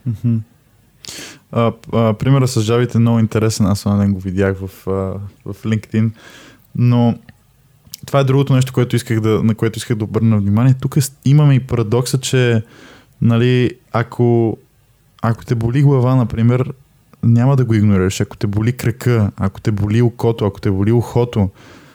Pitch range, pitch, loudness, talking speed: 110-125 Hz, 115 Hz, -16 LUFS, 165 wpm